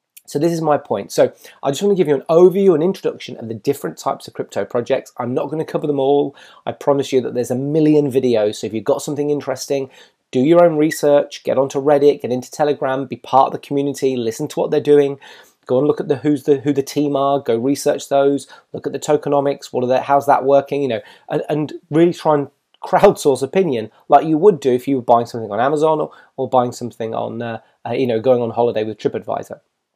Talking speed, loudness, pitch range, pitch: 245 wpm, -17 LUFS, 130-150 Hz, 140 Hz